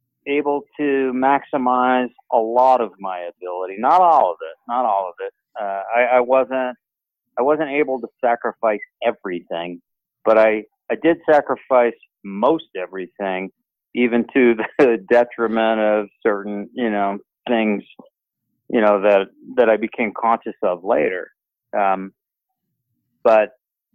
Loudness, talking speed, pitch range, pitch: -19 LUFS, 135 wpm, 105-130 Hz, 120 Hz